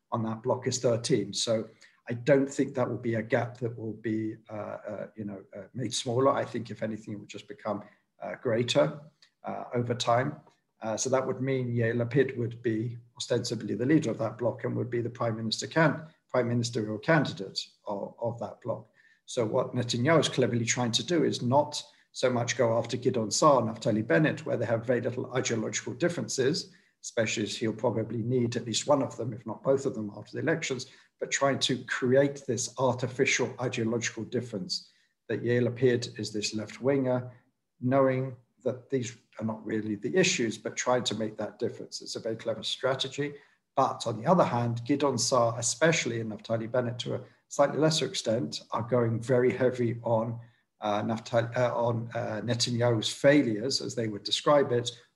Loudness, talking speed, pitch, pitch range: -29 LUFS, 195 wpm, 120 Hz, 110-130 Hz